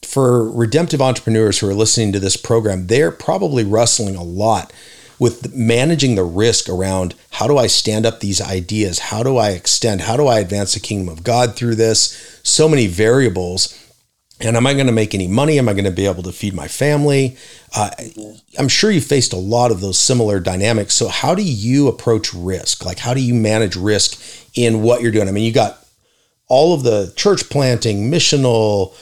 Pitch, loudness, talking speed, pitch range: 115 Hz, -15 LUFS, 205 wpm, 100-125 Hz